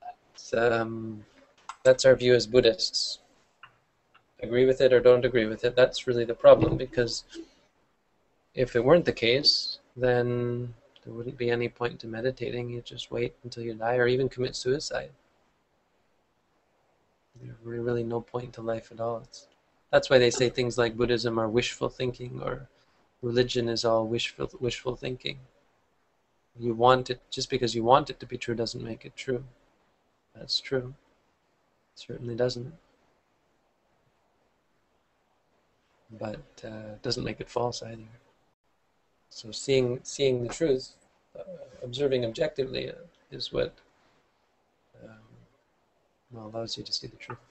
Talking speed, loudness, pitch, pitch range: 145 wpm, -27 LUFS, 120 Hz, 115-125 Hz